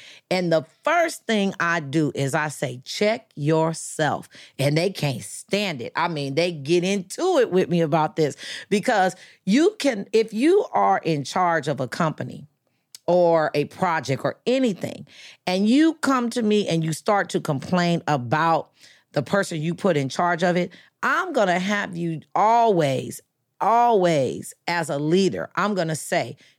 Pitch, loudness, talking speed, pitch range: 175 Hz, -22 LUFS, 165 wpm, 155-205 Hz